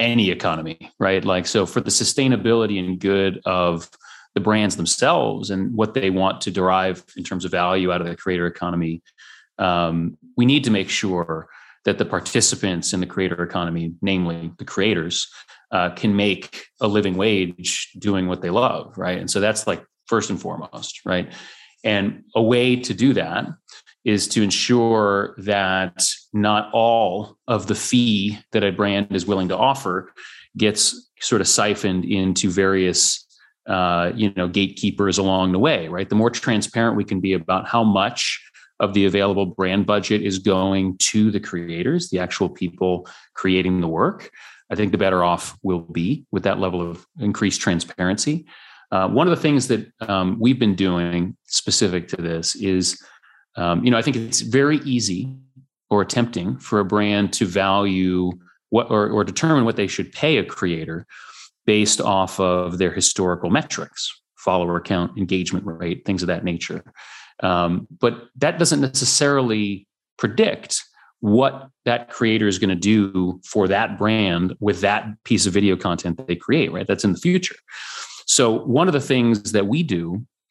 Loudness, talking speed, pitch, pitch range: -20 LUFS, 170 wpm, 100 Hz, 90-110 Hz